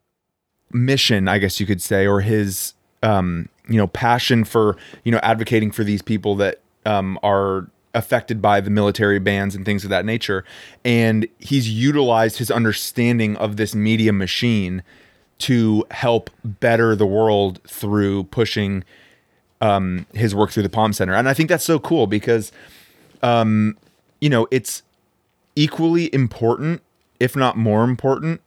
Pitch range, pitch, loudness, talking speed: 100-120 Hz, 110 Hz, -19 LUFS, 150 wpm